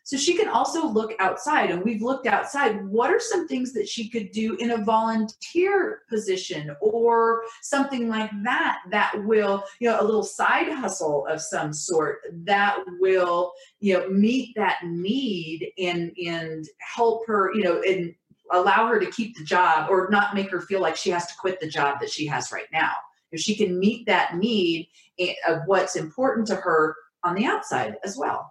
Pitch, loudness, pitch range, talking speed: 200 Hz, -24 LUFS, 175-230 Hz, 190 wpm